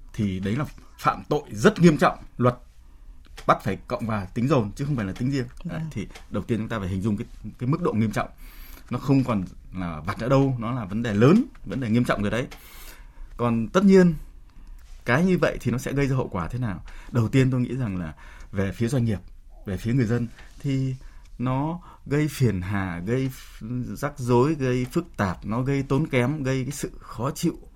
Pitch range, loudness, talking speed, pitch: 100-135 Hz, -25 LUFS, 220 wpm, 120 Hz